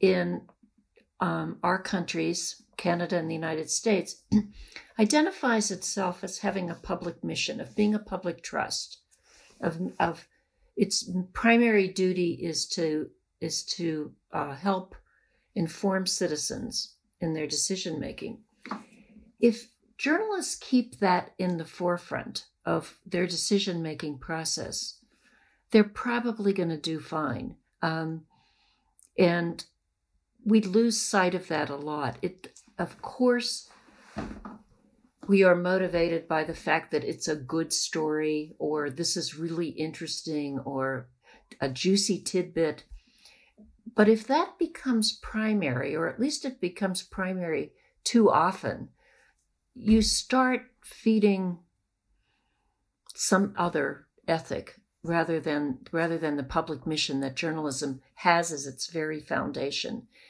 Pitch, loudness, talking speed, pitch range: 180 Hz, -28 LUFS, 120 wpm, 160-220 Hz